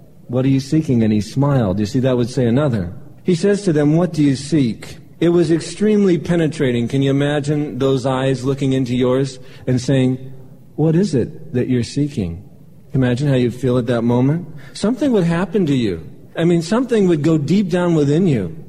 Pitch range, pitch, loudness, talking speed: 130-165 Hz, 140 Hz, -17 LUFS, 200 wpm